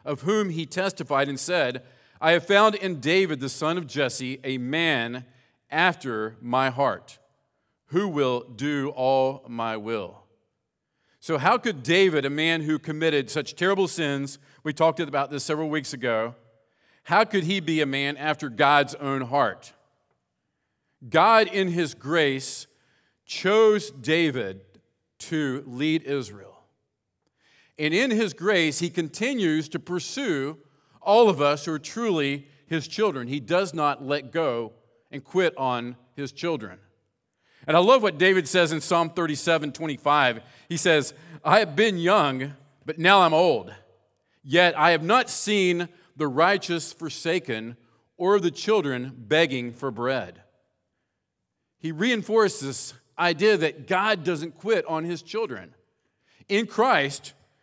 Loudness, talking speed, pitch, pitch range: -24 LUFS, 140 wpm, 155 Hz, 135-175 Hz